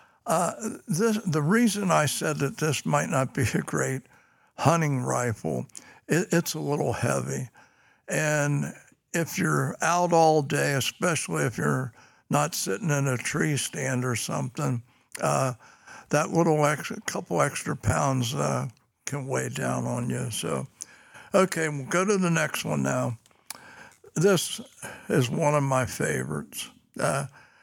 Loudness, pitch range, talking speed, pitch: -26 LUFS, 125-170 Hz, 145 wpm, 145 Hz